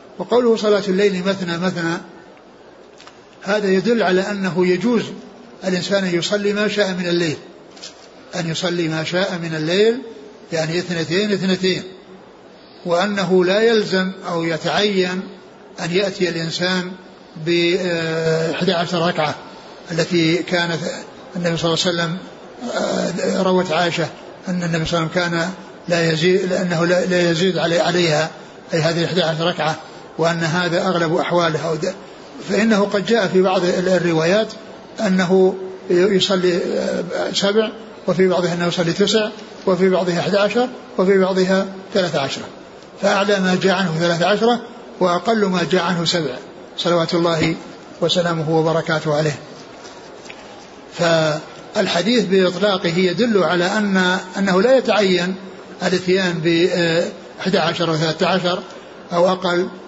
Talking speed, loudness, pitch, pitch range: 120 wpm, -18 LUFS, 180 Hz, 170-195 Hz